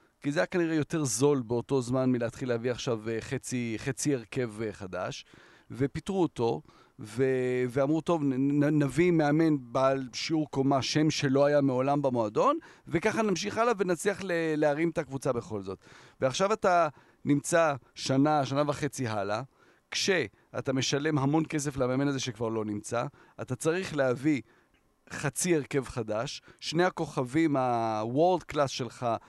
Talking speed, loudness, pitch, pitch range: 140 wpm, -29 LUFS, 140 Hz, 125-155 Hz